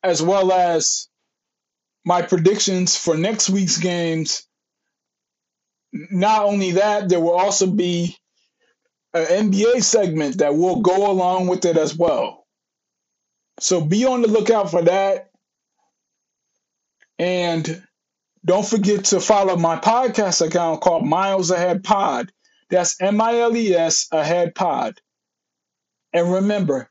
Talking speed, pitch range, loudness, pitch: 125 wpm, 175-205 Hz, -18 LUFS, 185 Hz